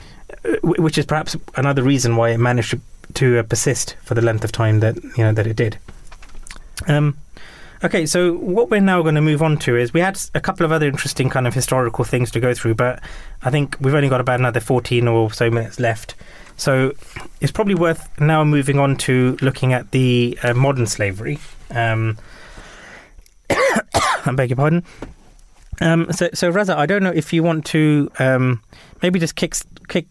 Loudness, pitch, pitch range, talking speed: -18 LUFS, 135 Hz, 120-155 Hz, 190 wpm